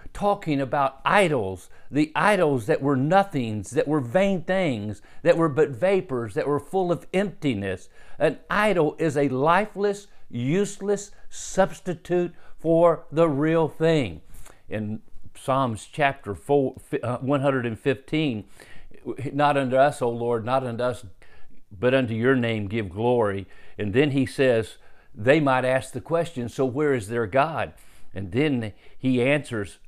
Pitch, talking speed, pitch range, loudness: 135 Hz, 135 wpm, 120-160 Hz, -24 LUFS